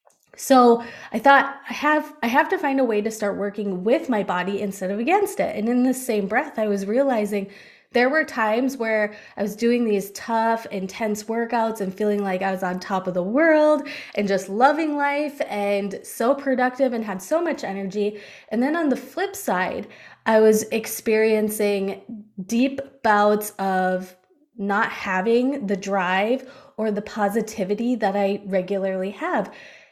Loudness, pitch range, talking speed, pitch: -22 LUFS, 200-260 Hz, 170 wpm, 220 Hz